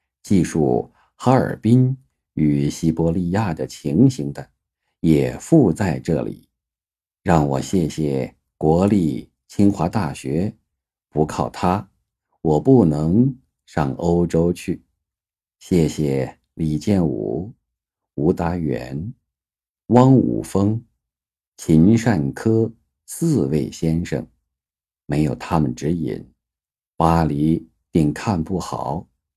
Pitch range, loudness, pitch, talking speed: 75-100 Hz, -20 LUFS, 80 Hz, 140 characters per minute